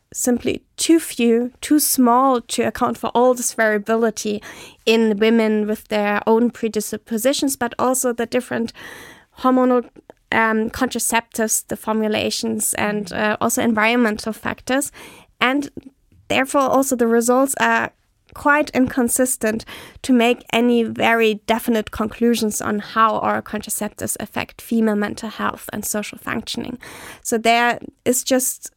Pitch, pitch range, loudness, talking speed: 235 Hz, 220-255 Hz, -19 LUFS, 125 wpm